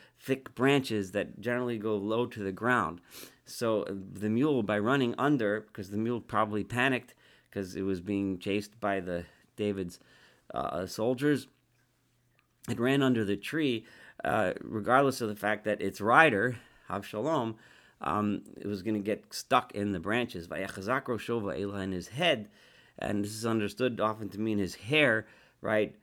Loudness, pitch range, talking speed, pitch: -31 LUFS, 100-120 Hz, 160 wpm, 105 Hz